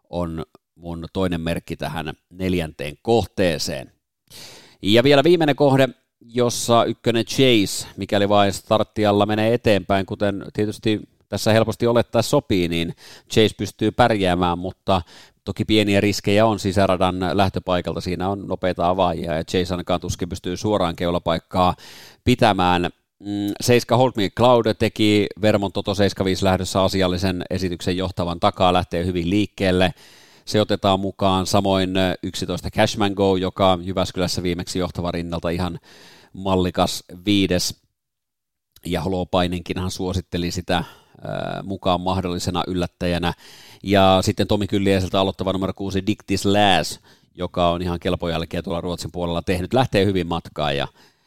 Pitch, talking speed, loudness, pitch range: 95 Hz, 125 wpm, -21 LUFS, 90-105 Hz